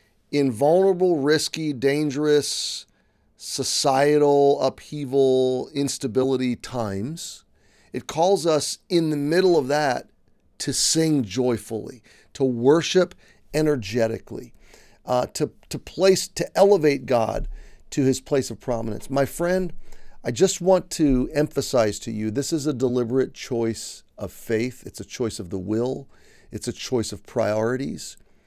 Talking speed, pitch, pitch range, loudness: 130 wpm, 135 Hz, 120-150 Hz, -23 LUFS